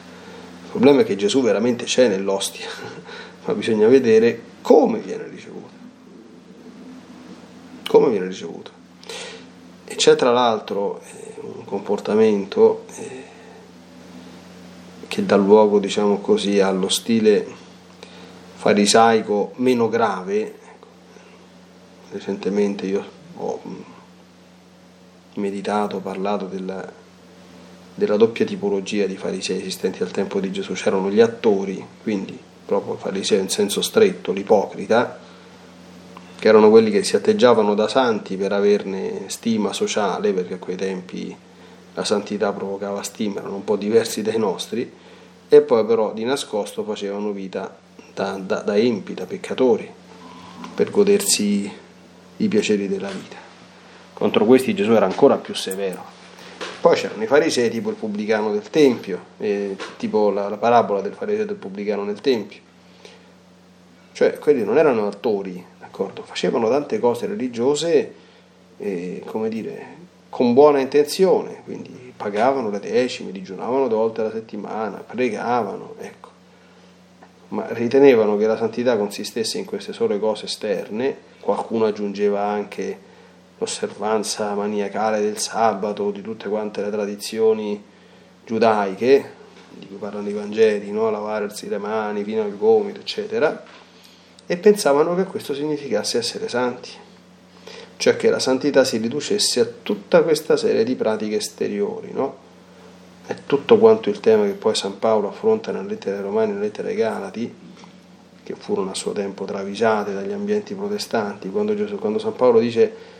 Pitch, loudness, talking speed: 115 Hz, -20 LUFS, 135 wpm